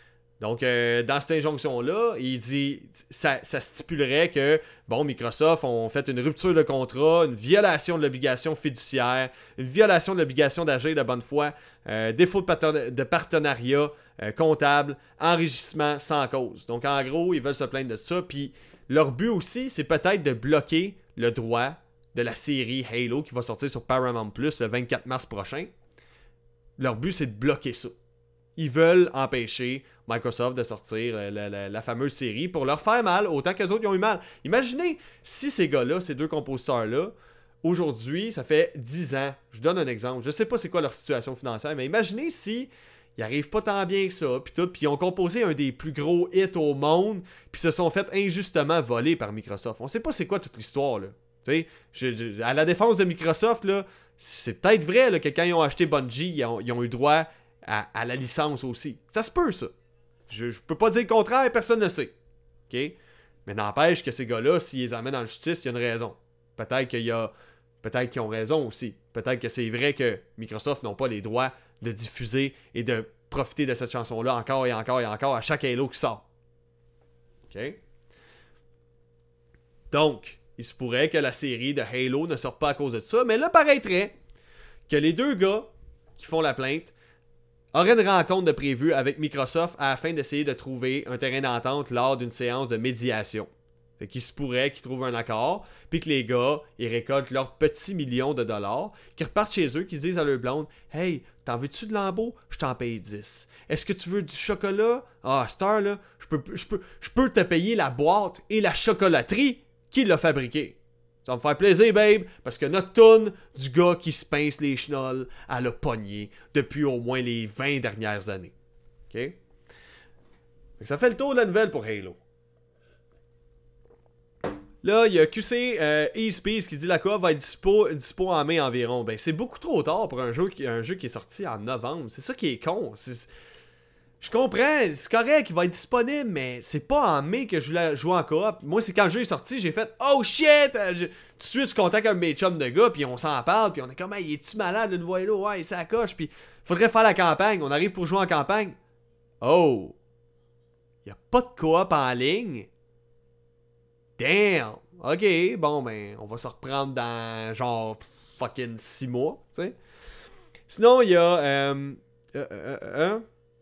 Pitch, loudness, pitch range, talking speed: 140 Hz, -25 LUFS, 120-175 Hz, 200 wpm